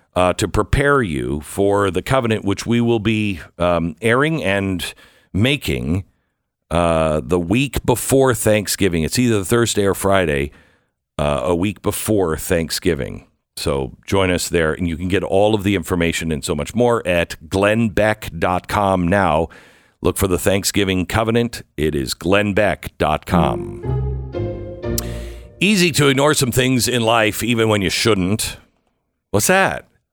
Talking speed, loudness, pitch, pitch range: 140 wpm, -18 LUFS, 100 Hz, 85-115 Hz